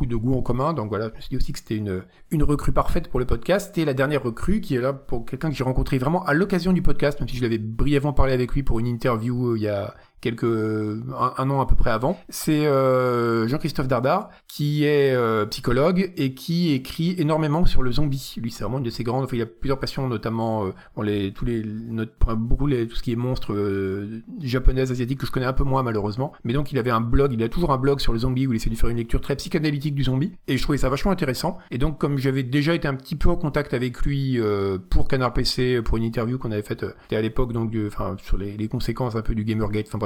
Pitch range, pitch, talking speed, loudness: 115-145 Hz, 130 Hz, 265 wpm, -24 LUFS